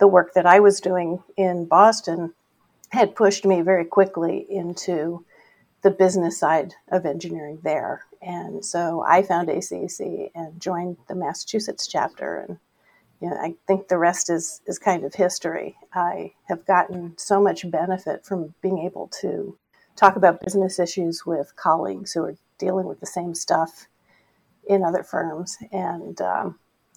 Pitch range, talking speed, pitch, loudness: 170-195 Hz, 155 wpm, 180 Hz, -22 LUFS